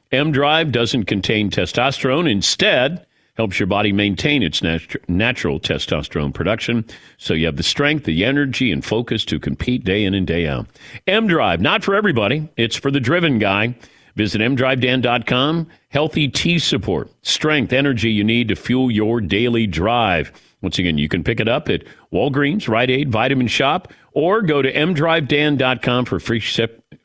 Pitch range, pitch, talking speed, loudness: 105-140 Hz, 120 Hz, 165 wpm, -18 LUFS